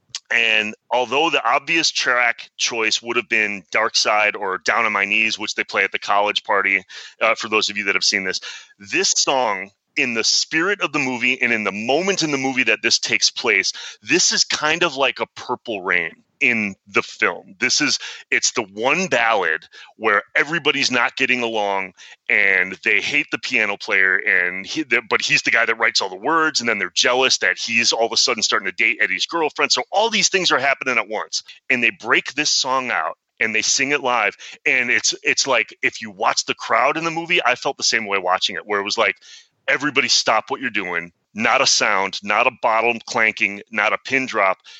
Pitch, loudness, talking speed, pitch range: 120 Hz, -18 LUFS, 220 wpm, 110-150 Hz